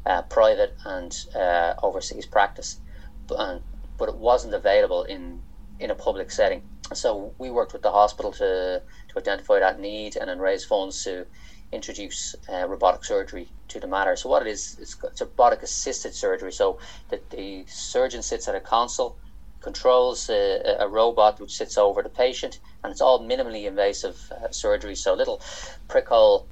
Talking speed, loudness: 170 wpm, -24 LUFS